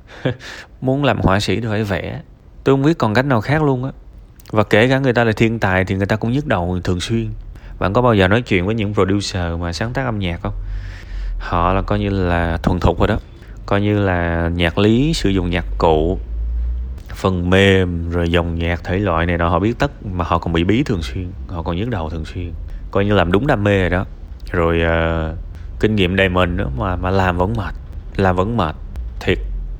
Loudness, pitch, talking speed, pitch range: -18 LUFS, 95 Hz, 230 wpm, 85-105 Hz